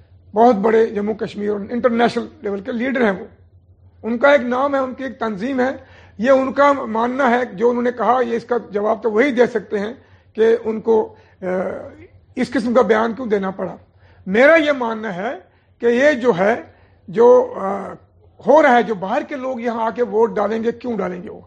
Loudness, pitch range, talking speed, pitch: -18 LUFS, 210-250 Hz, 210 wpm, 230 Hz